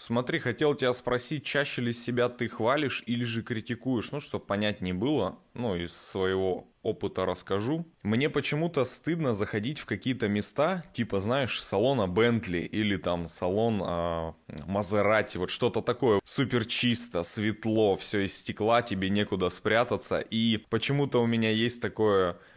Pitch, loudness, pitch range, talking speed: 110 Hz, -28 LUFS, 100-125 Hz, 145 wpm